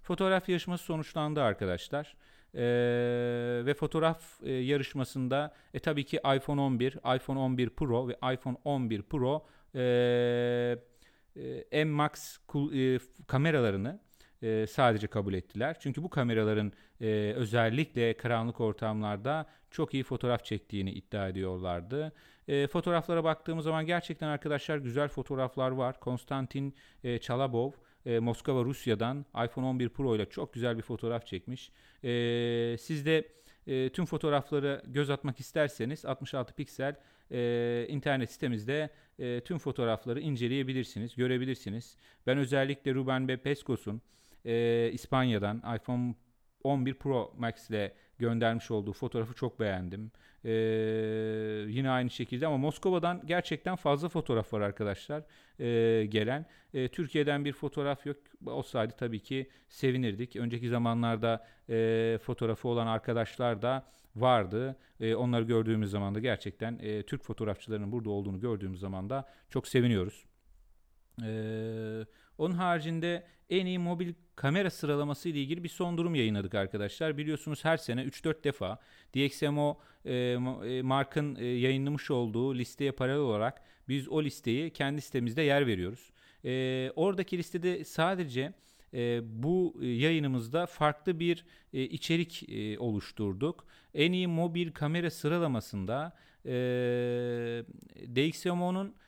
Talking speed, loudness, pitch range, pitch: 120 wpm, -33 LUFS, 115-150 Hz, 130 Hz